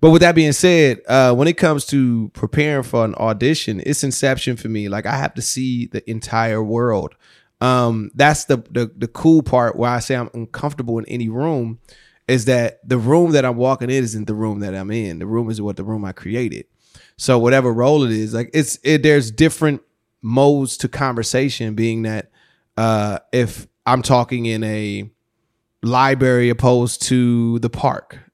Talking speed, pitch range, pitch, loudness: 190 wpm, 110-135 Hz, 120 Hz, -17 LUFS